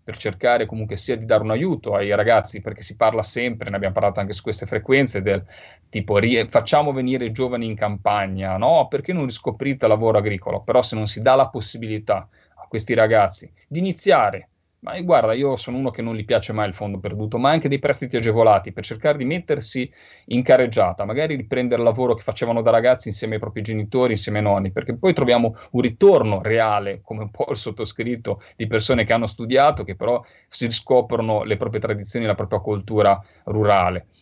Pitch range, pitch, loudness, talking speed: 105-125 Hz, 115 Hz, -20 LUFS, 200 wpm